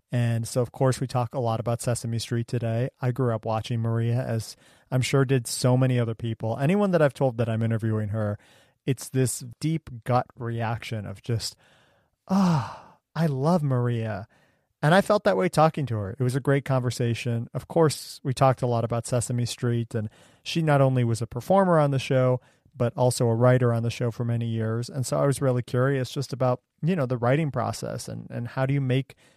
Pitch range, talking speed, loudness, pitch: 115-135 Hz, 215 wpm, -25 LUFS, 125 Hz